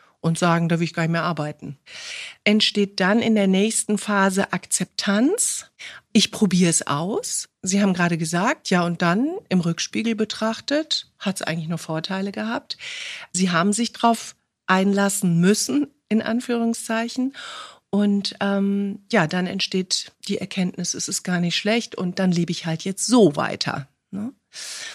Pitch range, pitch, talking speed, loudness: 180-225 Hz, 200 Hz, 155 wpm, -22 LUFS